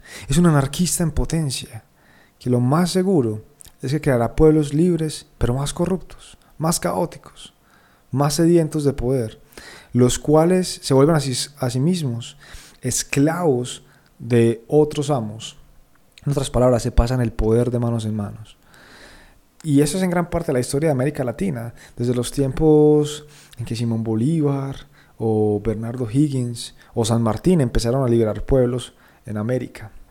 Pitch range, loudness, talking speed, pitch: 115-150 Hz, -20 LUFS, 155 wpm, 130 Hz